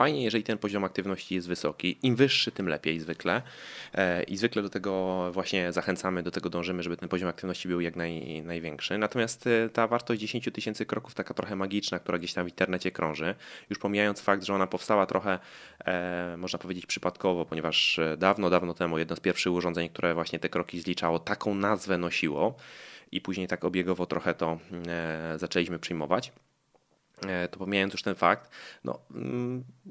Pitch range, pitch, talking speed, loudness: 85-100 Hz, 90 Hz, 170 wpm, -30 LUFS